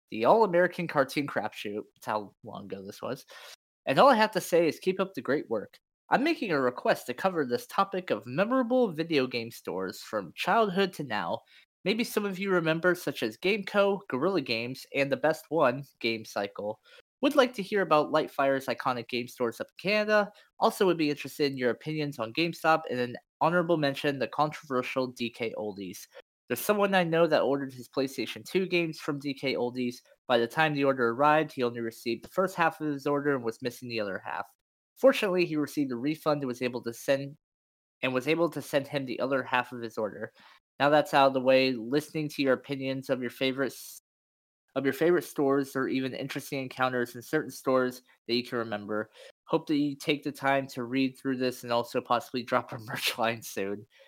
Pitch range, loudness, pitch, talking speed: 125-165 Hz, -29 LUFS, 140 Hz, 205 wpm